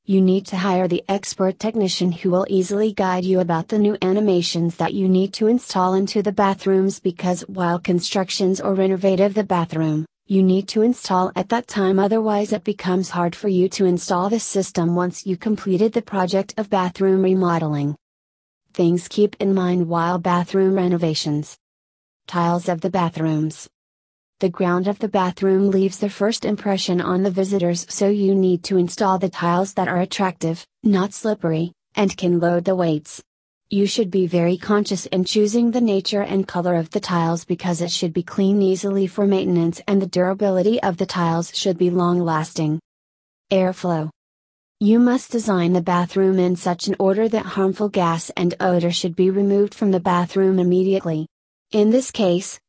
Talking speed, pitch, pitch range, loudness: 175 wpm, 185 Hz, 175-200 Hz, -20 LUFS